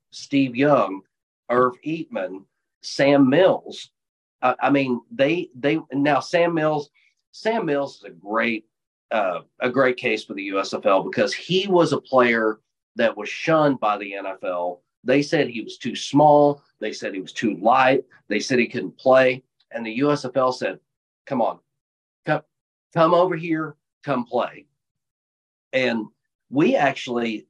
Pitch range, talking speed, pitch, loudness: 110-150 Hz, 150 wpm, 130 Hz, -21 LUFS